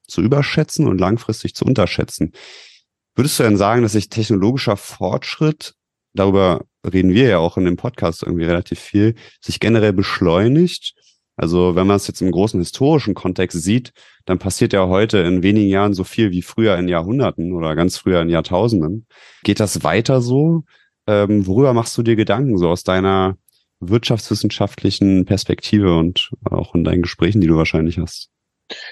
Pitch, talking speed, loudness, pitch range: 100 Hz, 165 wpm, -17 LUFS, 90-115 Hz